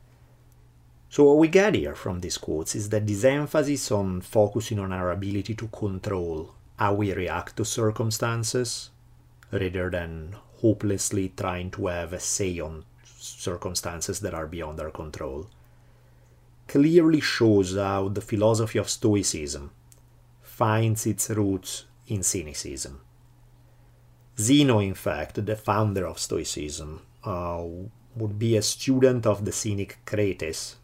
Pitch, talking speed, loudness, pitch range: 105 Hz, 130 wpm, -25 LUFS, 95-120 Hz